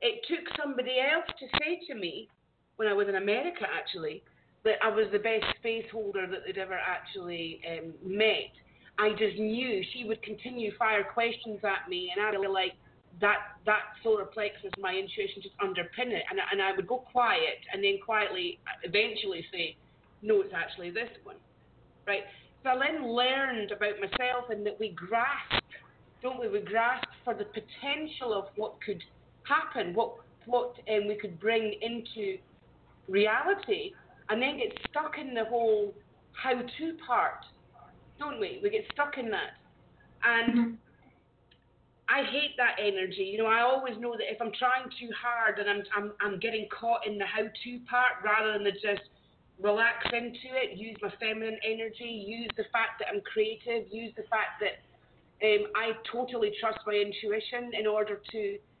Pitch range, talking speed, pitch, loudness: 210-255 Hz, 175 wpm, 225 Hz, -31 LUFS